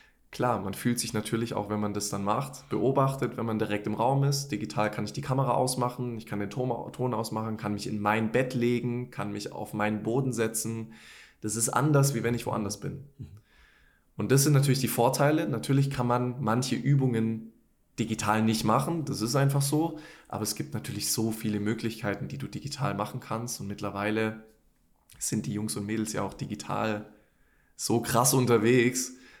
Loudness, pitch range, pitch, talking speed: -29 LUFS, 105-130 Hz, 115 Hz, 190 wpm